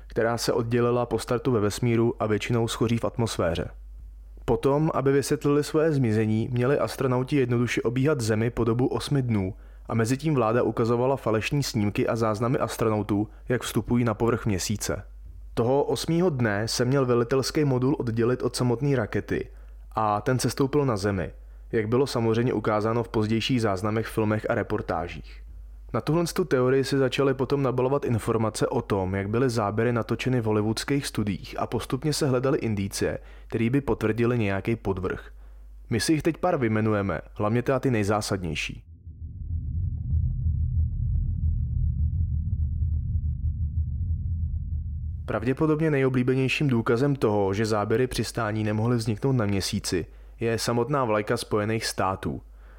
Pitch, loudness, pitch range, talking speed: 115 Hz, -26 LUFS, 100-130 Hz, 140 wpm